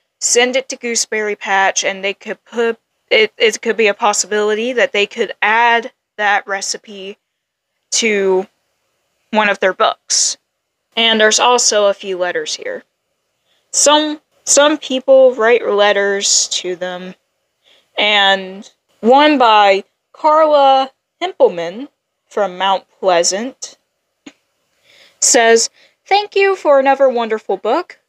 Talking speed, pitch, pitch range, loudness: 120 wpm, 225 Hz, 200-275 Hz, -13 LUFS